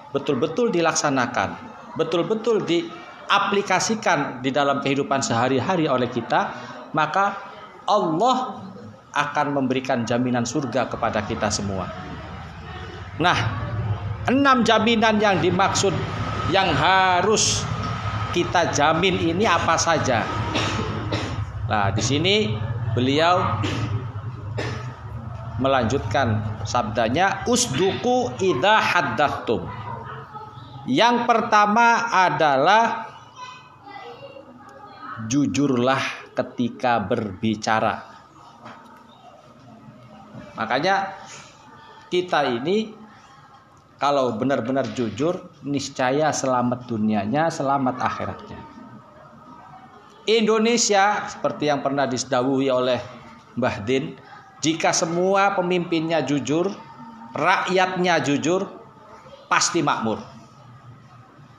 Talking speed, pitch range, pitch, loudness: 70 wpm, 115-190 Hz, 140 Hz, -21 LUFS